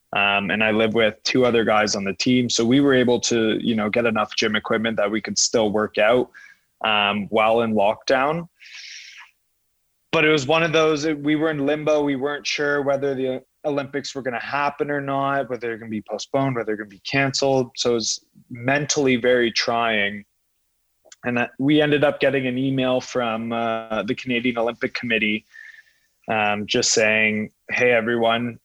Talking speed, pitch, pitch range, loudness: 195 wpm, 125 Hz, 110-140 Hz, -21 LUFS